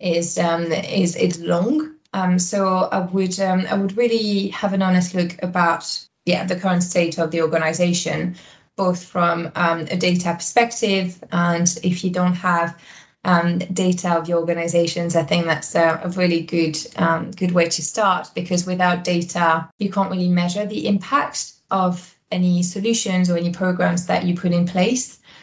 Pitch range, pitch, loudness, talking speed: 170-190 Hz, 180 Hz, -20 LUFS, 170 wpm